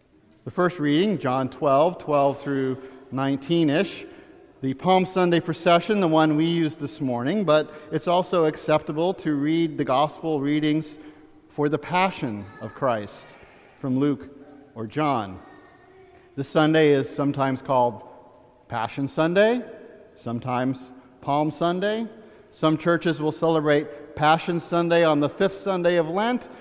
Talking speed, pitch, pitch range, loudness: 135 wpm, 155 Hz, 140-170 Hz, -23 LUFS